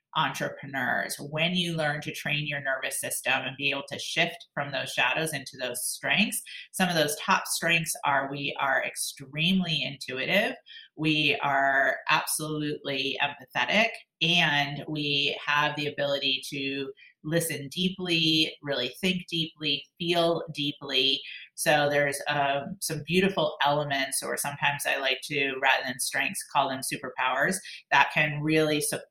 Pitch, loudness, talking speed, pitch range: 150 Hz, -26 LUFS, 140 wpm, 140-165 Hz